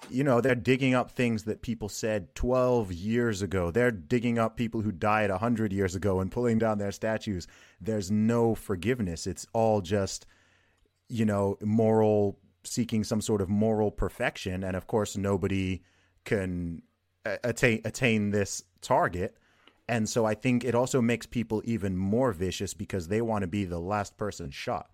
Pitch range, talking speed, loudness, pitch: 100-115 Hz, 170 wpm, -29 LUFS, 105 Hz